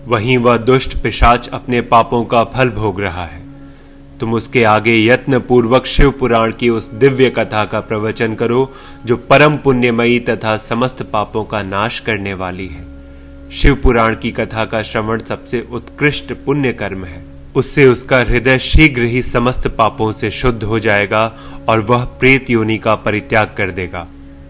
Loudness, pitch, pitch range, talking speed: -14 LUFS, 115 Hz, 105-125 Hz, 160 wpm